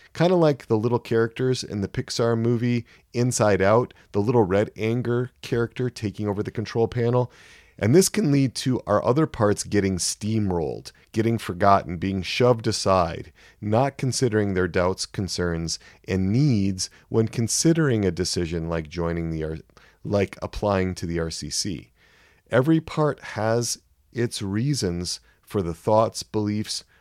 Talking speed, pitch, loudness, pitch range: 145 wpm, 110 Hz, -24 LUFS, 95-120 Hz